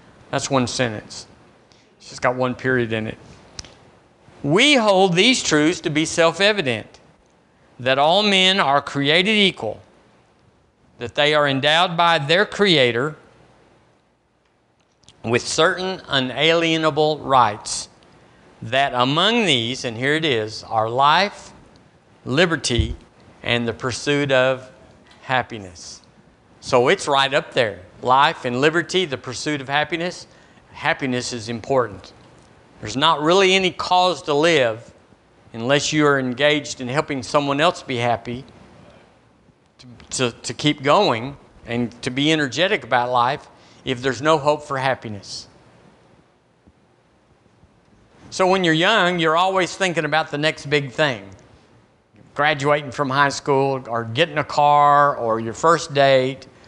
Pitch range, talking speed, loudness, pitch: 125-160 Hz, 130 wpm, -19 LUFS, 145 Hz